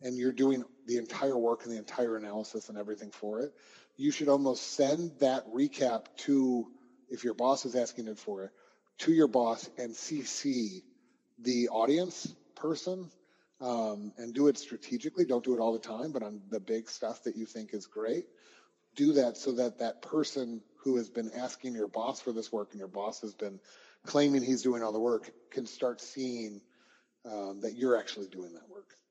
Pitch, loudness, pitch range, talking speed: 125 Hz, -33 LUFS, 110-140 Hz, 195 wpm